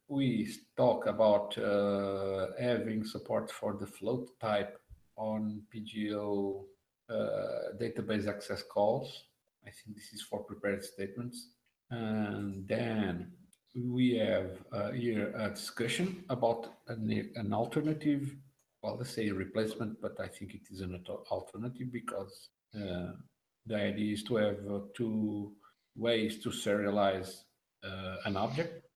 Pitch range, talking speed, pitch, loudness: 100-120 Hz, 125 wpm, 110 Hz, -35 LUFS